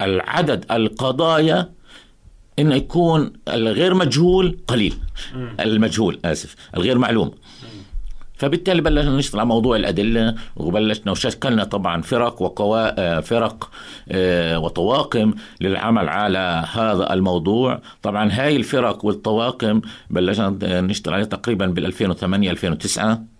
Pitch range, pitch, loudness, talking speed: 95-125 Hz, 110 Hz, -19 LUFS, 100 wpm